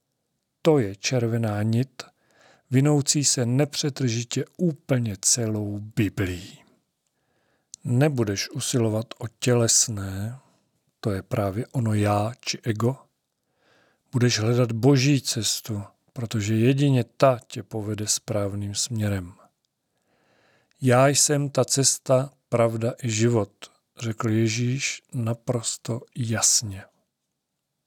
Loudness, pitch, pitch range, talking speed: -23 LUFS, 120 Hz, 110-135 Hz, 95 wpm